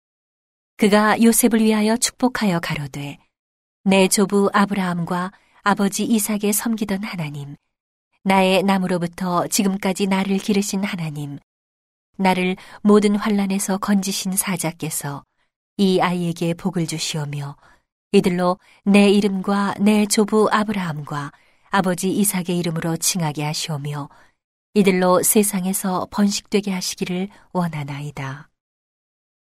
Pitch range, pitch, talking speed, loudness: 170-205 Hz, 190 Hz, 270 characters per minute, -19 LUFS